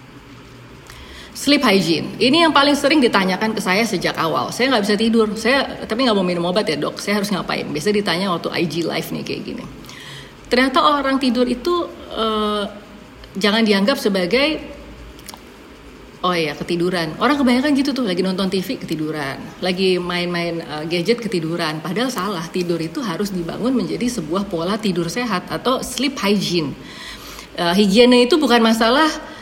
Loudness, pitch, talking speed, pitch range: -18 LUFS, 205 Hz, 160 wpm, 175-245 Hz